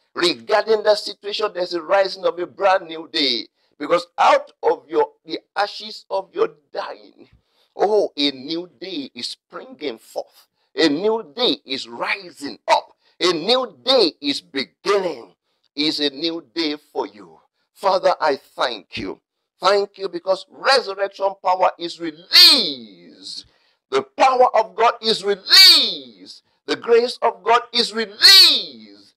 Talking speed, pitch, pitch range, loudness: 140 wpm, 200 Hz, 175-250 Hz, -17 LUFS